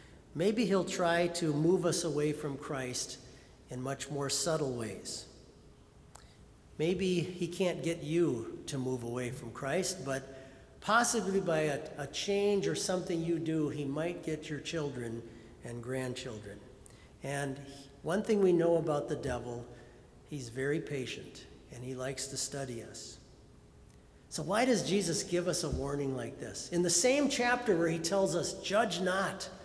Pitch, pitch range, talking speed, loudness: 150 Hz, 130-175 Hz, 160 wpm, -33 LUFS